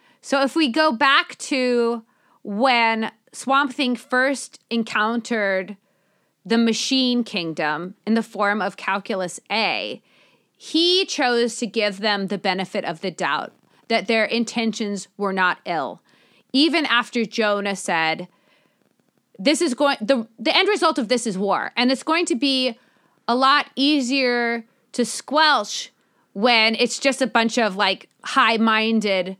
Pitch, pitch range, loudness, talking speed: 230 Hz, 205-265 Hz, -20 LUFS, 140 wpm